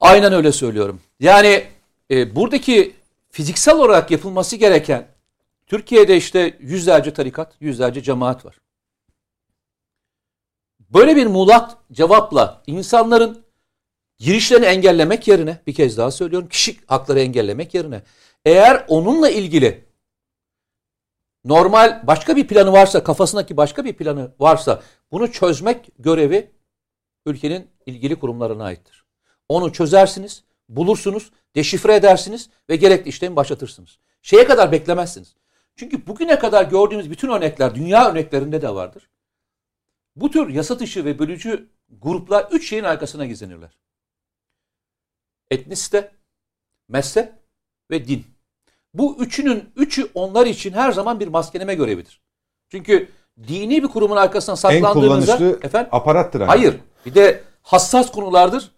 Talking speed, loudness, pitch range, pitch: 115 wpm, -15 LUFS, 135-215 Hz, 180 Hz